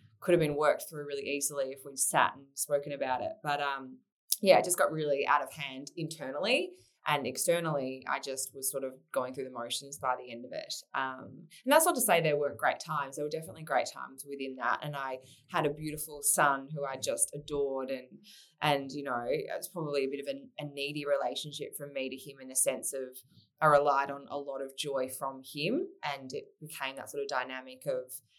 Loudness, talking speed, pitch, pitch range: -32 LUFS, 225 wpm, 140 Hz, 135-150 Hz